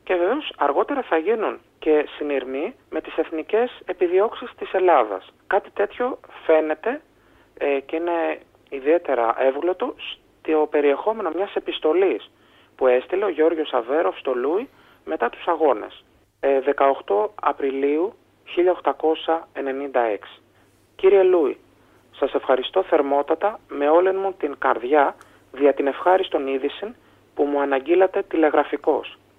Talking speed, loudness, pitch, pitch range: 115 wpm, -22 LUFS, 155 Hz, 140-195 Hz